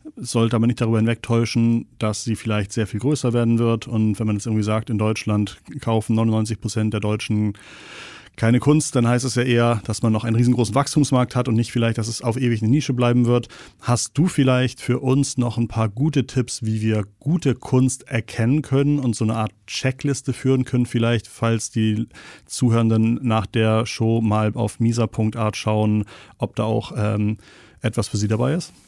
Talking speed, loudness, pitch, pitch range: 195 wpm, -21 LUFS, 115 Hz, 110-125 Hz